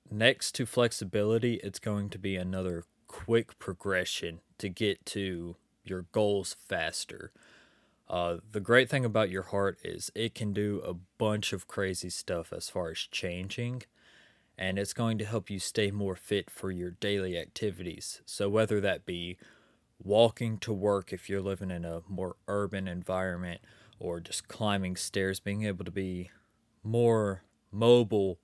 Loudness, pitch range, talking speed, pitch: -32 LUFS, 95-110 Hz, 155 wpm, 100 Hz